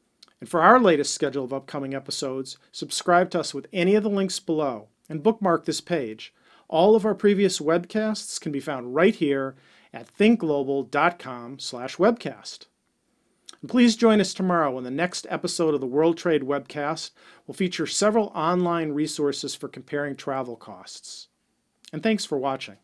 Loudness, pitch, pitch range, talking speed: -24 LUFS, 155 Hz, 140-185 Hz, 160 wpm